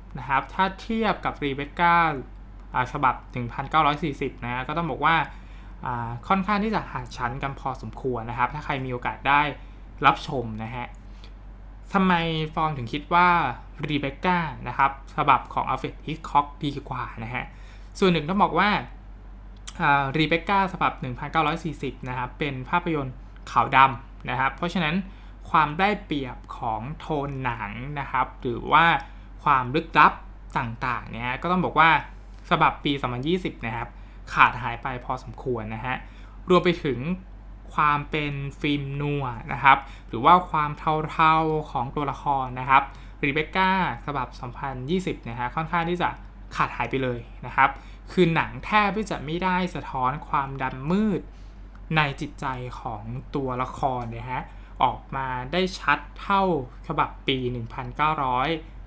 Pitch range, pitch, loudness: 120-160 Hz, 135 Hz, -25 LUFS